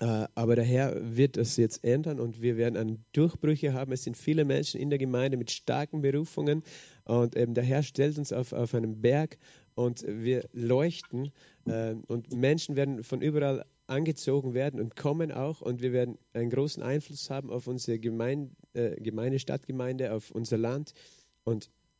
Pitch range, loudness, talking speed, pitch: 120-145 Hz, -31 LUFS, 175 wpm, 130 Hz